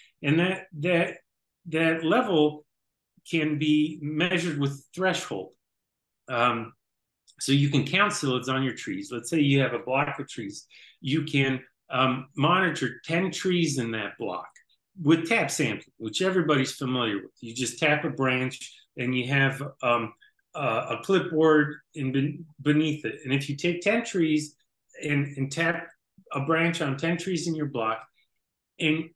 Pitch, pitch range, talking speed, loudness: 150 Hz, 130-165 Hz, 155 wpm, -26 LUFS